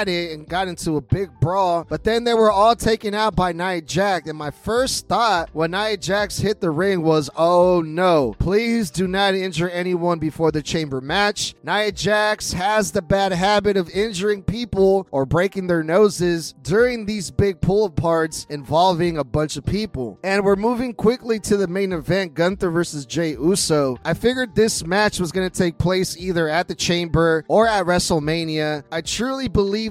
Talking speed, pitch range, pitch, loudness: 185 wpm, 165-205 Hz, 185 Hz, -20 LUFS